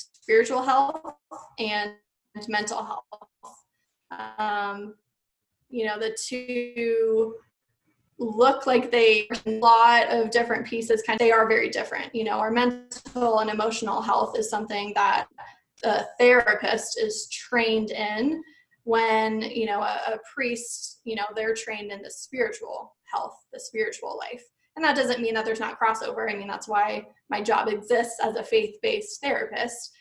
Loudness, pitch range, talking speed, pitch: -24 LUFS, 215-250 Hz, 150 wpm, 230 Hz